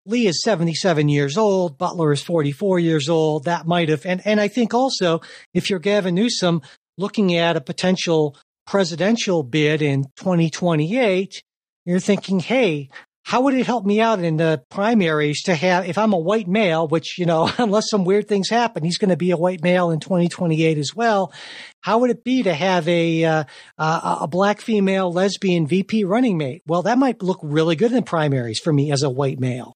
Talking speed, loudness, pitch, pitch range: 200 wpm, -19 LUFS, 180 Hz, 160-205 Hz